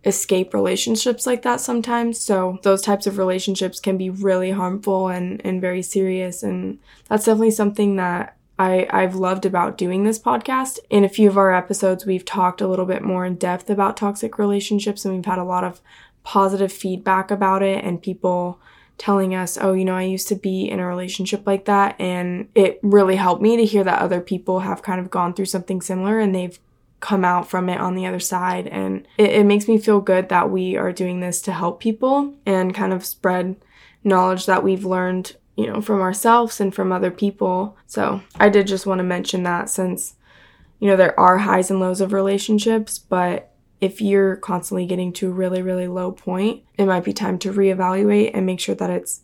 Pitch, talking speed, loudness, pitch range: 190 Hz, 210 wpm, -20 LUFS, 185-200 Hz